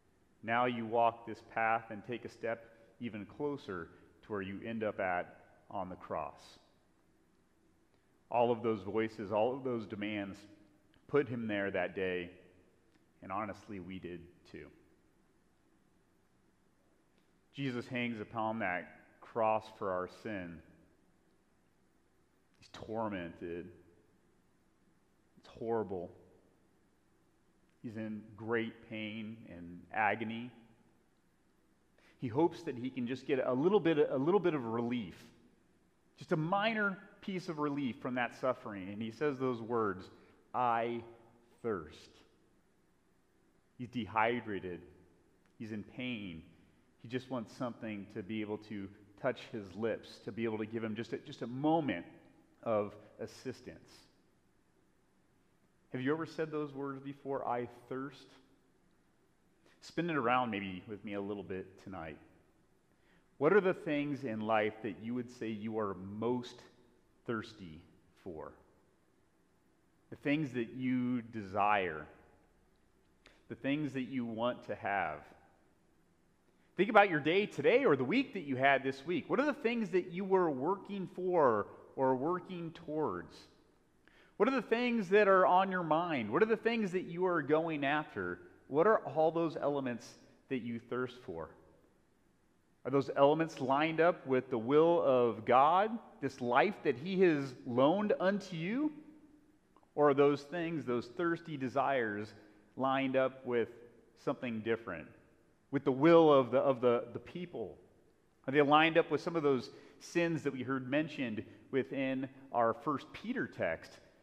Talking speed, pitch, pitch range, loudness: 140 wpm, 125 Hz, 110-150 Hz, -35 LUFS